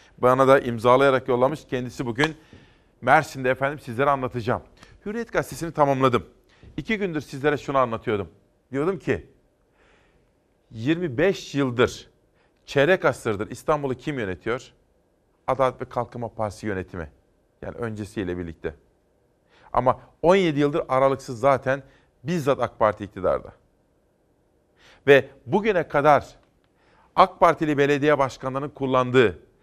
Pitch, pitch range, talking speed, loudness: 130 Hz, 120-145 Hz, 105 wpm, -23 LUFS